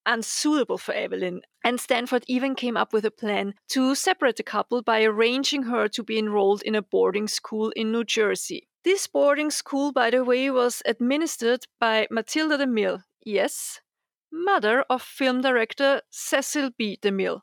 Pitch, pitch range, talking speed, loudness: 245 Hz, 220-275 Hz, 160 wpm, -24 LUFS